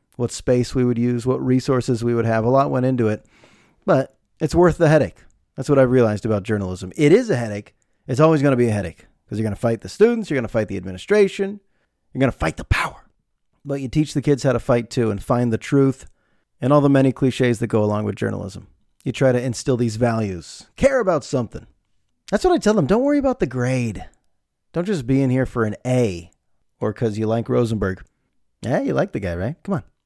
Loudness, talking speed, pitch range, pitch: -20 LUFS, 240 wpm, 110-140 Hz, 125 Hz